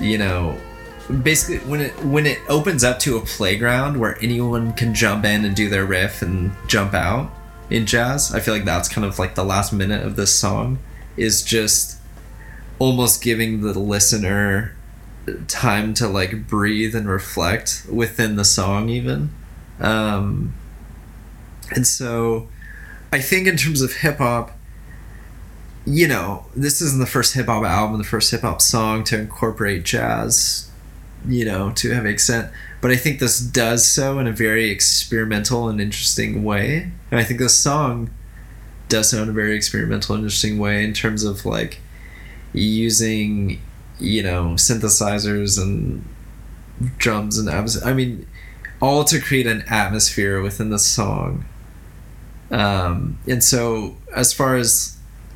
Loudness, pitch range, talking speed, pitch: -18 LUFS, 100-120 Hz, 155 wpm, 110 Hz